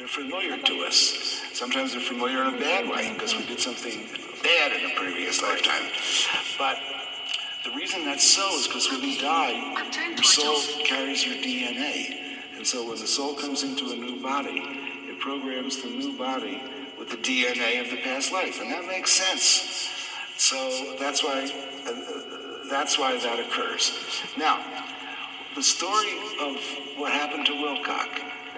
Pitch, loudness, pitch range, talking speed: 140 Hz, -25 LUFS, 135-150 Hz, 160 wpm